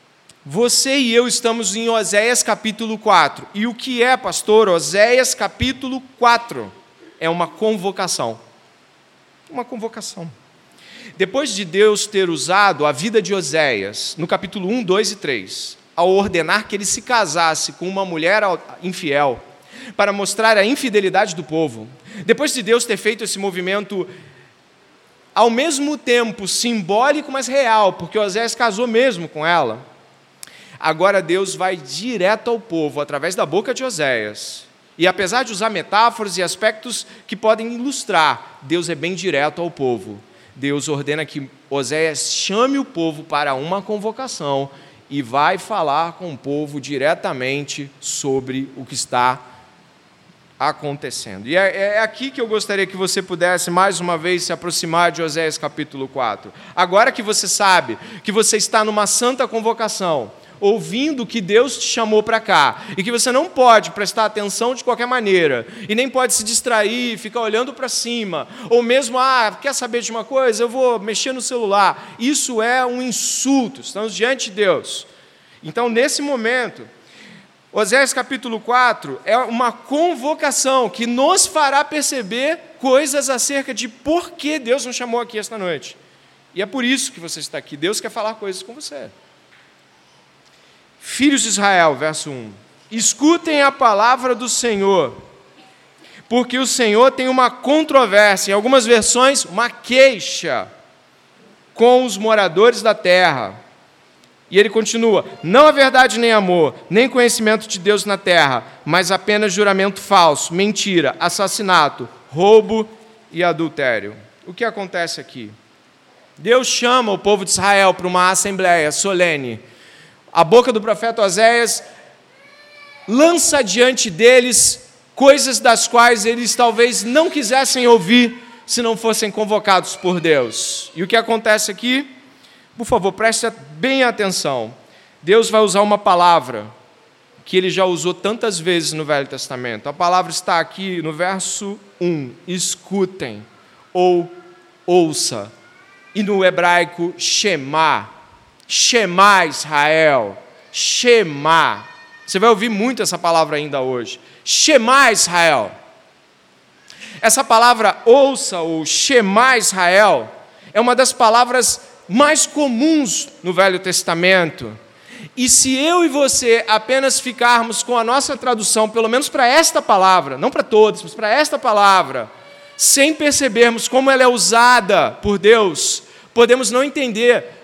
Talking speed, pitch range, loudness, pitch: 140 wpm, 180-245 Hz, -16 LUFS, 215 Hz